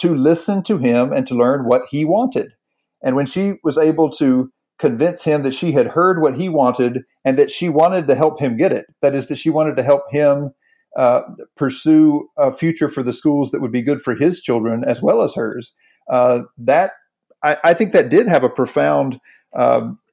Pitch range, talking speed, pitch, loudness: 130-170 Hz, 210 wpm, 150 Hz, -17 LUFS